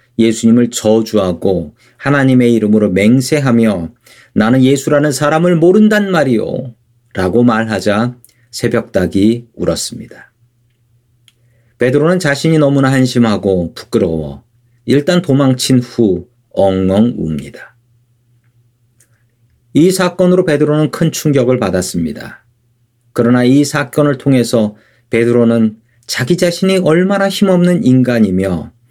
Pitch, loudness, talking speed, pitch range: 120 Hz, -12 LUFS, 260 characters per minute, 115-140 Hz